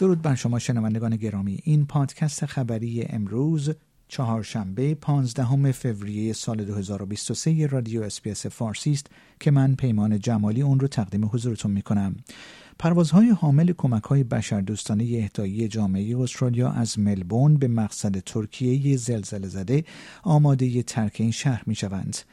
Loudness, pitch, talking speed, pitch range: -24 LUFS, 120 Hz, 130 wpm, 105-140 Hz